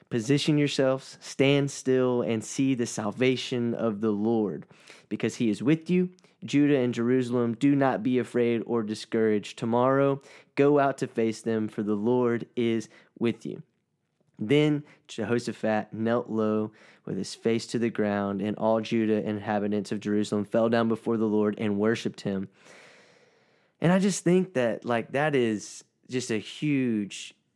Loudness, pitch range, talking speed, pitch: -27 LUFS, 110-135 Hz, 155 wpm, 115 Hz